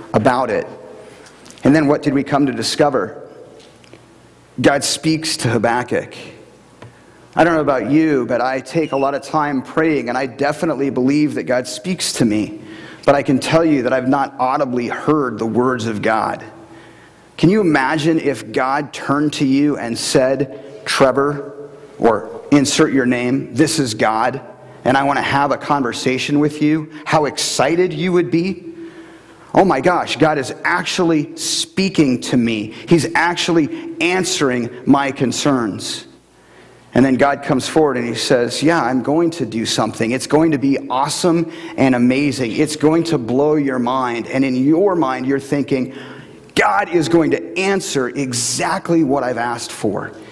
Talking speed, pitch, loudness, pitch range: 165 wpm, 140 Hz, -17 LUFS, 130-160 Hz